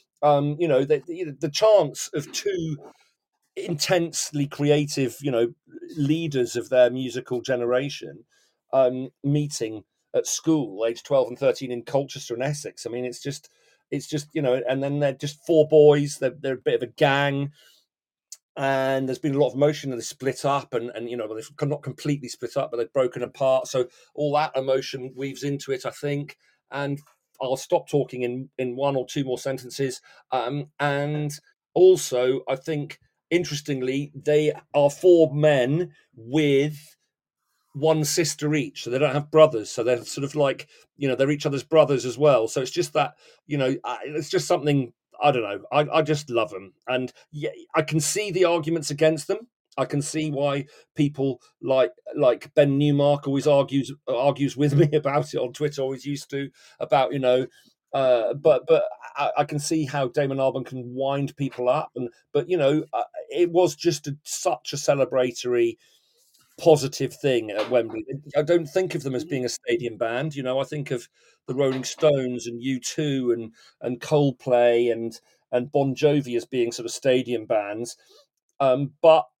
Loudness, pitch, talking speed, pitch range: -24 LUFS, 140 Hz, 185 wpm, 130-155 Hz